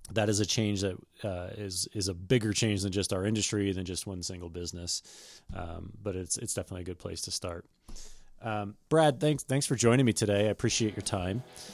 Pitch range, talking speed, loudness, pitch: 95-110 Hz, 215 wpm, -31 LUFS, 100 Hz